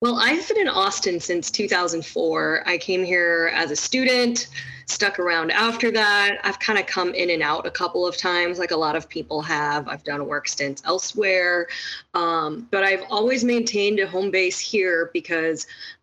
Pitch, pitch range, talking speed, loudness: 180 Hz, 165-210 Hz, 185 wpm, -21 LUFS